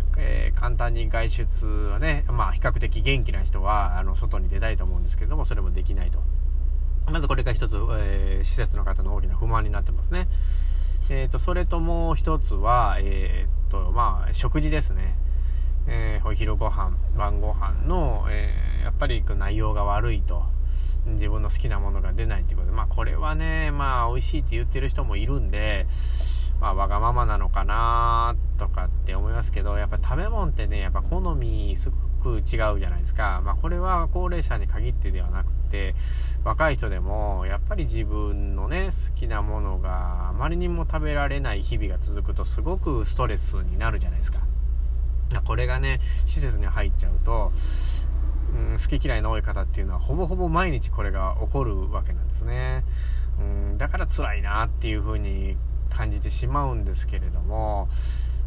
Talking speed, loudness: 360 characters per minute, -26 LUFS